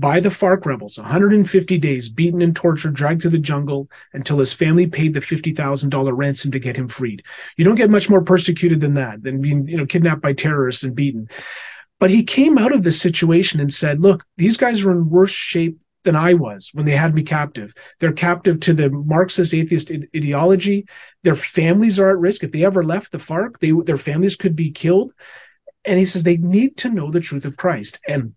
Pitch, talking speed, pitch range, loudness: 170 Hz, 215 wpm, 145-185 Hz, -17 LUFS